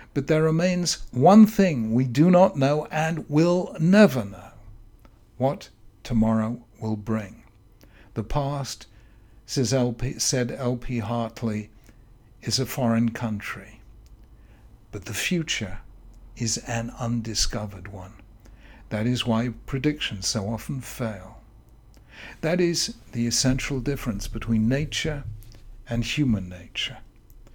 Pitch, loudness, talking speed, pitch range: 115 Hz, -24 LUFS, 115 wpm, 110-135 Hz